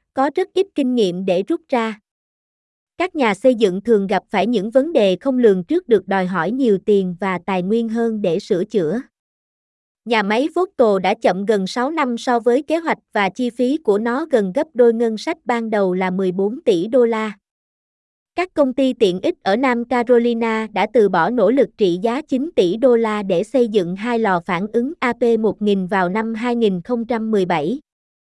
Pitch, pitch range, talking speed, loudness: 230 Hz, 200-255 Hz, 195 wpm, -18 LUFS